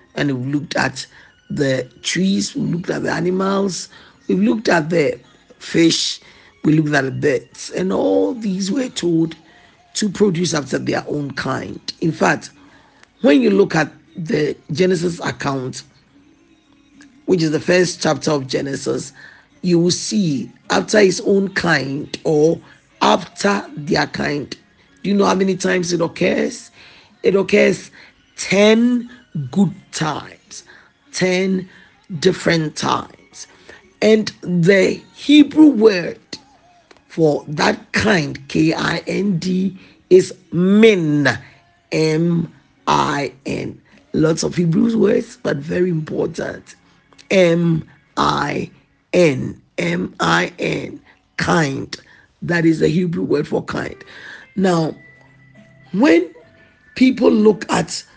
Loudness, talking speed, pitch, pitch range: -17 LUFS, 110 wpm, 180 Hz, 155-205 Hz